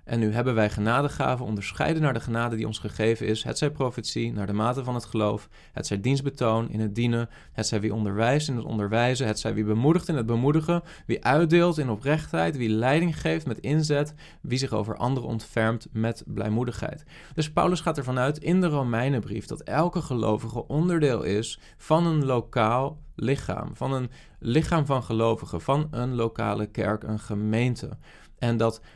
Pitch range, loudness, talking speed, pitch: 110-145 Hz, -26 LUFS, 180 wpm, 120 Hz